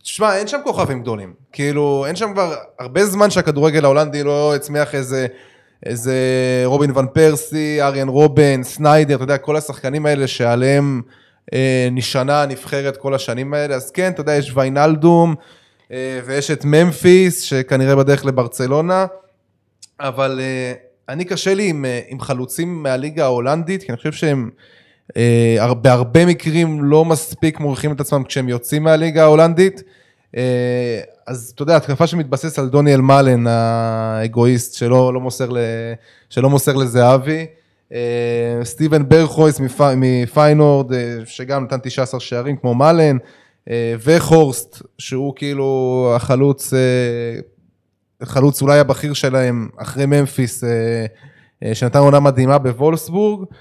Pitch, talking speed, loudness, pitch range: 140 Hz, 135 wpm, -15 LUFS, 125-150 Hz